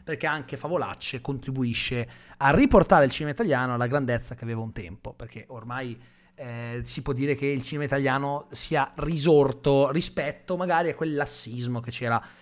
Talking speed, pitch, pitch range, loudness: 165 wpm, 135 Hz, 120-145 Hz, -25 LUFS